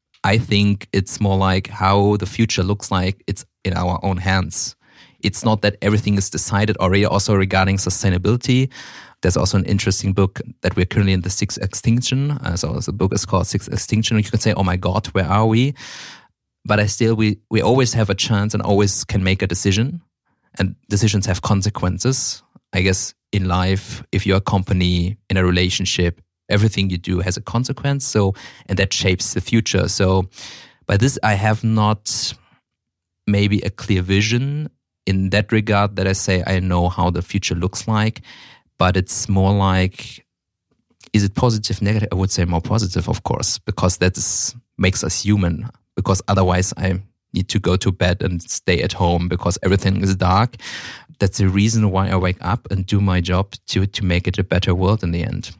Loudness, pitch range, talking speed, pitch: -19 LUFS, 95-110 Hz, 190 wpm, 100 Hz